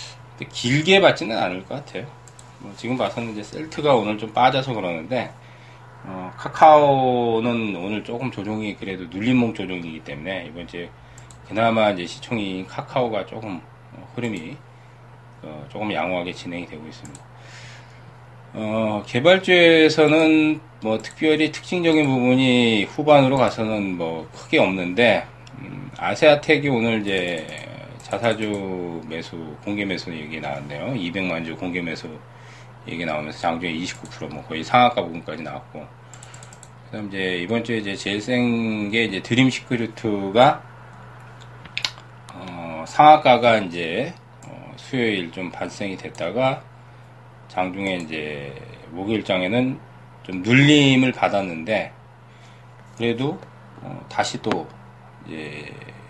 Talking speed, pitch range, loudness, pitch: 265 characters per minute, 95-125 Hz, -20 LUFS, 115 Hz